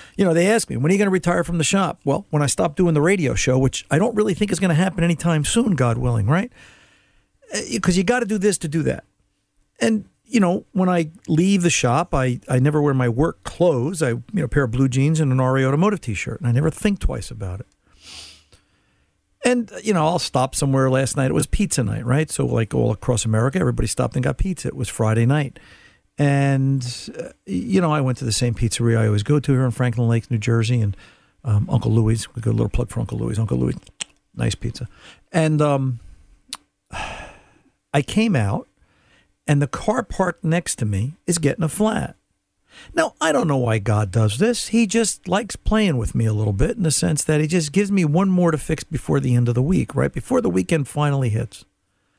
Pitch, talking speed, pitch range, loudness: 140 Hz, 230 wpm, 115-175 Hz, -20 LUFS